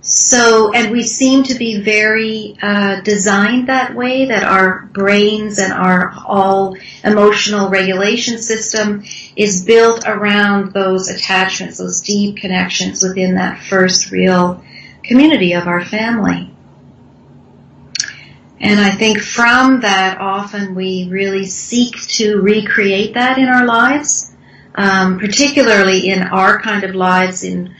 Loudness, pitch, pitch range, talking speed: -12 LUFS, 205 Hz, 190-225 Hz, 125 wpm